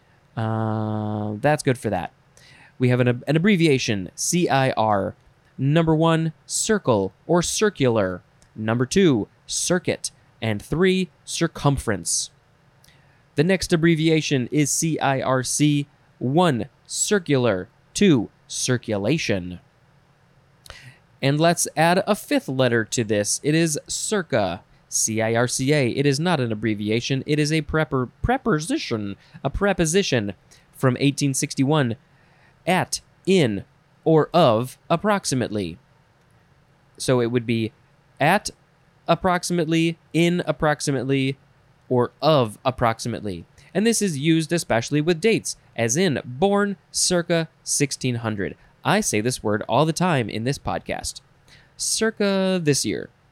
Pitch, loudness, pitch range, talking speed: 145 Hz, -22 LUFS, 125-160 Hz, 115 wpm